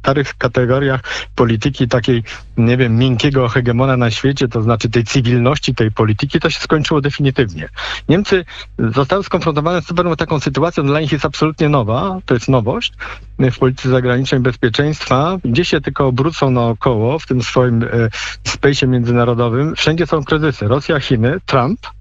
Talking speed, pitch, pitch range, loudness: 160 wpm, 130 Hz, 120-155 Hz, -15 LUFS